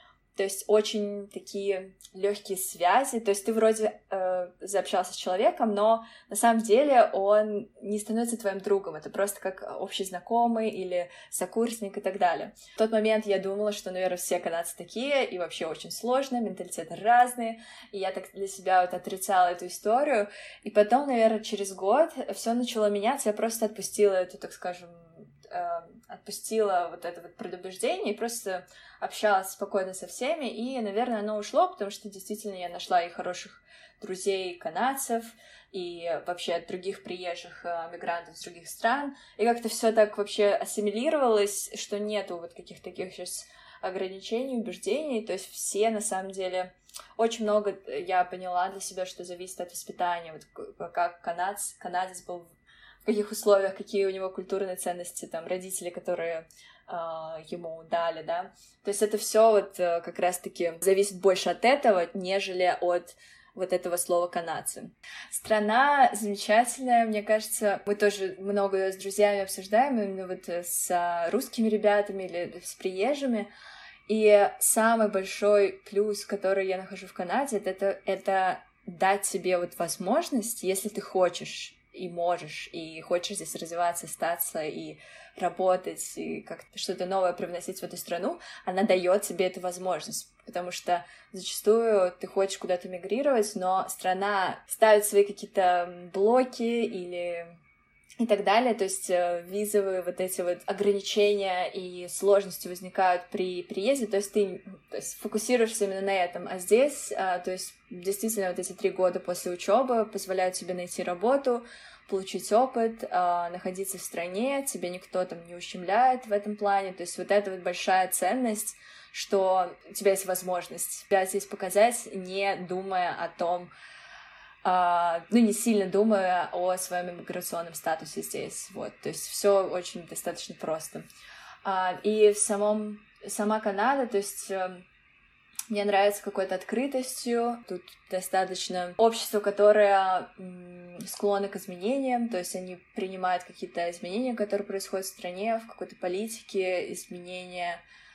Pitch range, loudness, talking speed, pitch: 180-215 Hz, -28 LUFS, 150 wpm, 195 Hz